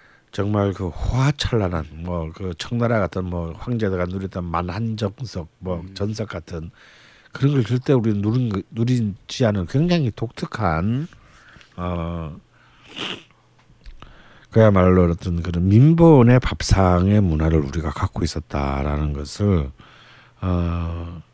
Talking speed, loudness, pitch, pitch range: 230 characters per minute, -21 LUFS, 95 Hz, 85-115 Hz